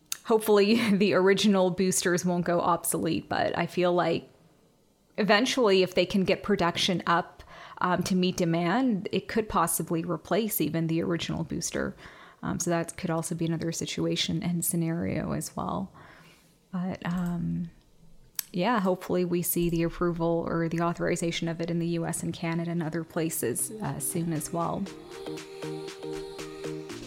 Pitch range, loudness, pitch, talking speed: 165-185 Hz, -28 LUFS, 170 Hz, 150 wpm